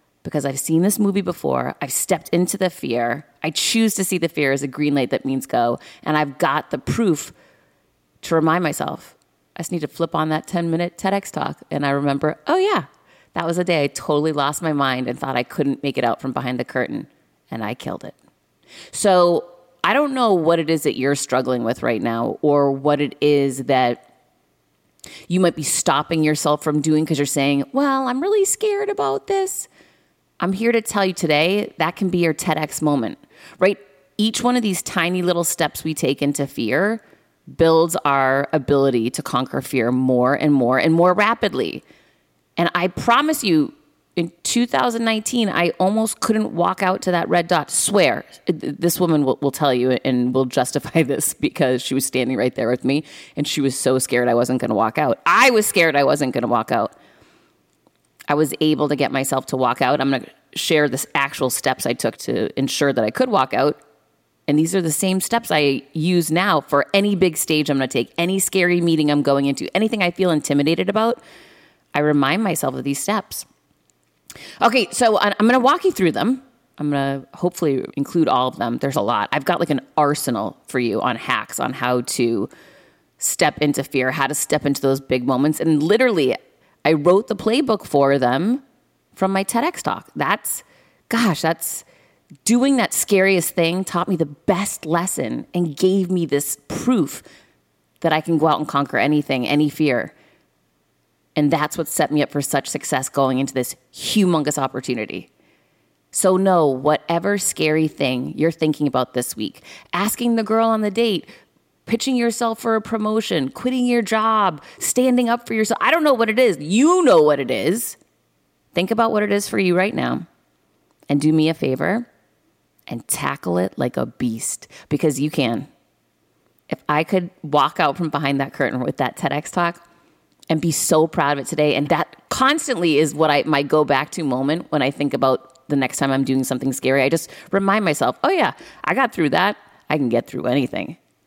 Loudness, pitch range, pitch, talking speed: -19 LUFS, 140-190 Hz, 155 Hz, 195 wpm